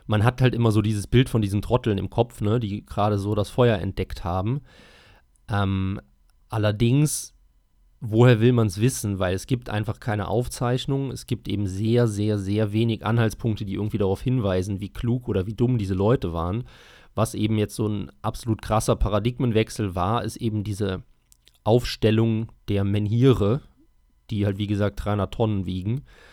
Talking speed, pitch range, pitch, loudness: 170 wpm, 100-120 Hz, 105 Hz, -24 LUFS